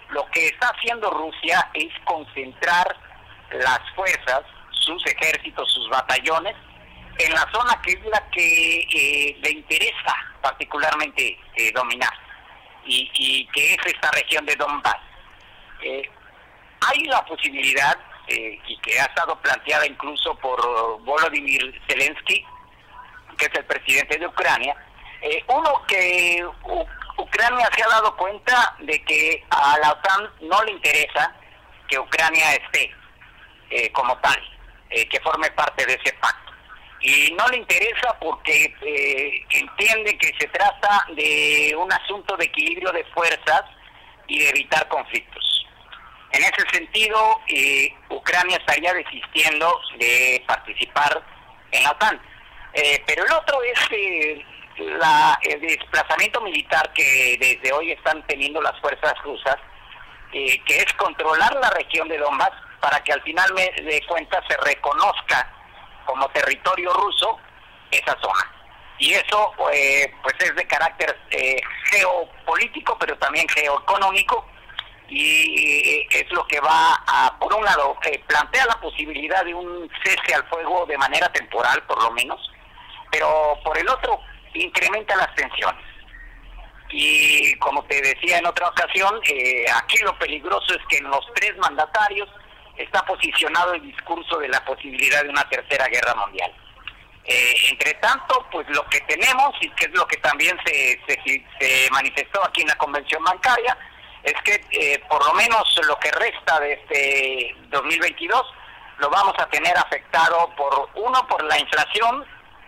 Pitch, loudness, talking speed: 190 Hz, -19 LUFS, 145 wpm